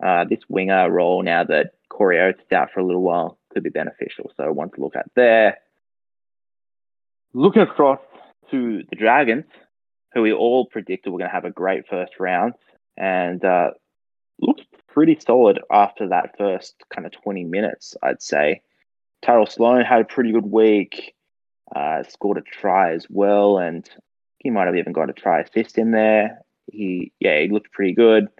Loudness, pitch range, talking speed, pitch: -19 LUFS, 95-125 Hz, 180 wpm, 110 Hz